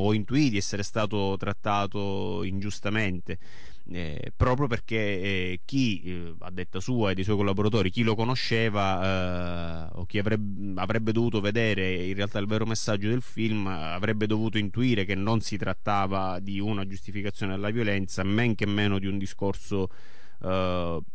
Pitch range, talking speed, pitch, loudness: 95-110 Hz, 160 wpm, 100 Hz, -28 LUFS